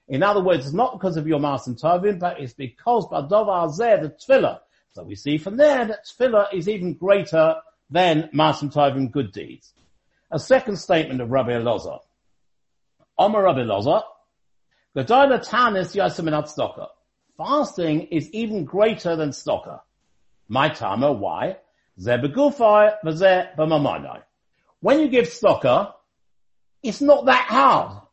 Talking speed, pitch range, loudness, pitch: 135 wpm, 145-220 Hz, -20 LUFS, 175 Hz